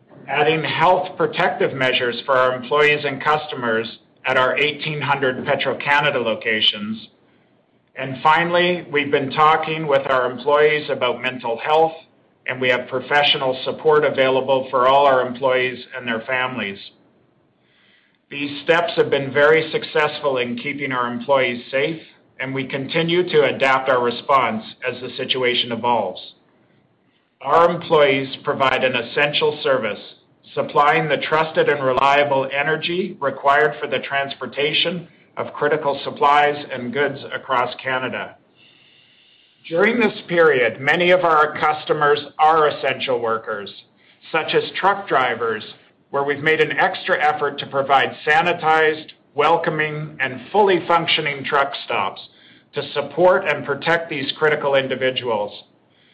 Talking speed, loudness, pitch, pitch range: 130 wpm, -19 LUFS, 145 Hz, 130-155 Hz